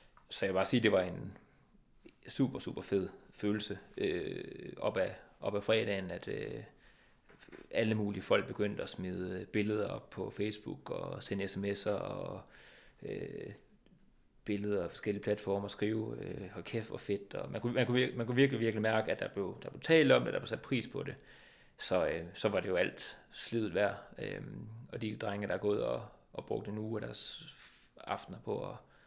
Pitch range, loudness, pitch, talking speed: 100-115 Hz, -36 LUFS, 105 Hz, 205 wpm